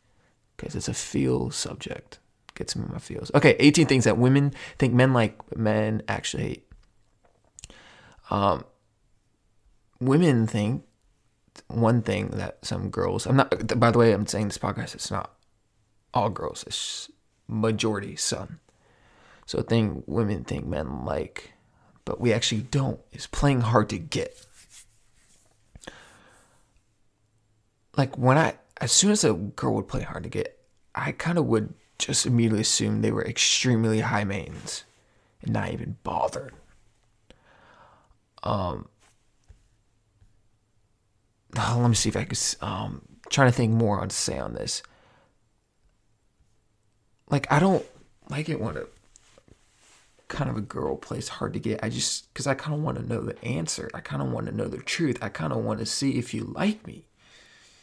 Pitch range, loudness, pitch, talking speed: 105-125 Hz, -25 LUFS, 110 Hz, 155 wpm